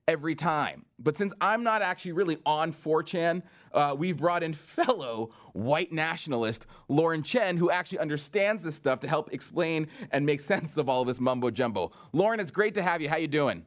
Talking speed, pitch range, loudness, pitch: 200 wpm, 145-175 Hz, -29 LUFS, 160 Hz